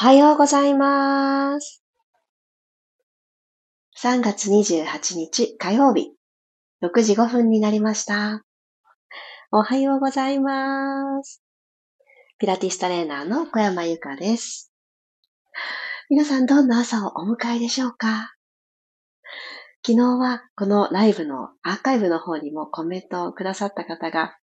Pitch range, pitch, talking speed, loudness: 195-275 Hz, 235 Hz, 230 characters per minute, -21 LUFS